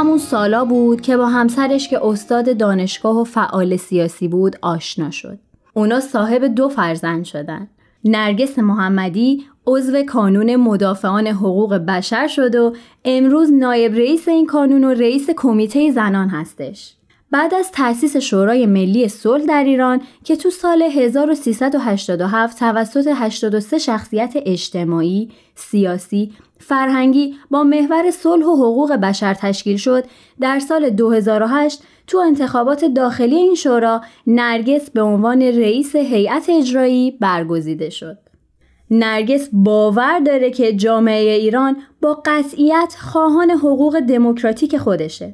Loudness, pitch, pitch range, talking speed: -15 LUFS, 240 Hz, 210-280 Hz, 125 wpm